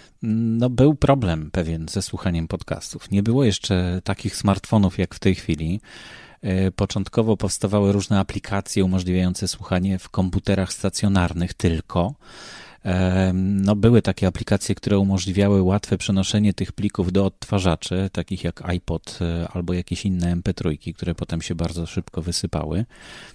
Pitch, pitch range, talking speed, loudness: 95 Hz, 90-100 Hz, 130 wpm, -22 LUFS